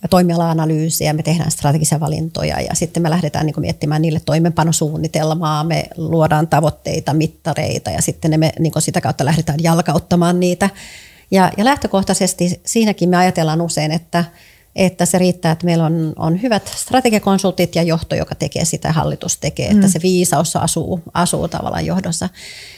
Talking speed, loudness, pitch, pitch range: 135 wpm, -16 LUFS, 165 Hz, 155-180 Hz